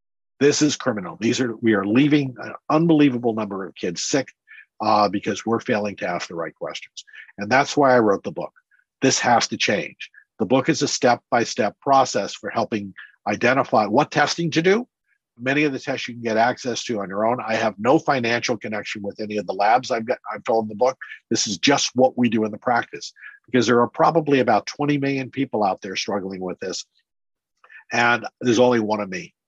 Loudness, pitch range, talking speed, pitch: -21 LUFS, 110-140 Hz, 210 wpm, 120 Hz